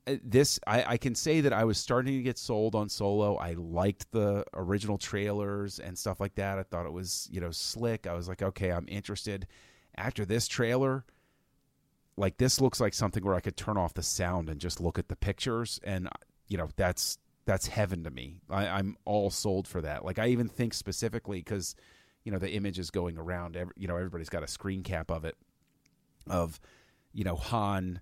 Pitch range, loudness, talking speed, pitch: 90-110 Hz, -32 LUFS, 210 wpm, 100 Hz